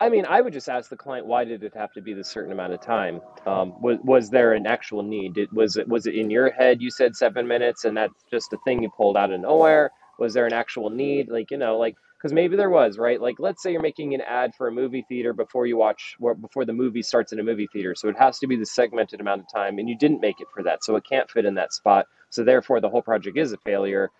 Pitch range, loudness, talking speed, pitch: 105-130 Hz, -23 LUFS, 290 wpm, 120 Hz